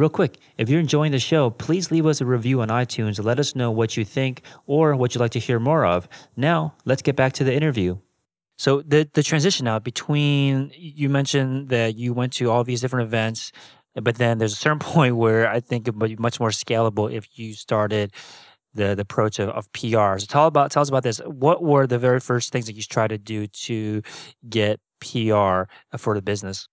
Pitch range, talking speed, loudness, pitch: 110-140 Hz, 220 wpm, -22 LUFS, 120 Hz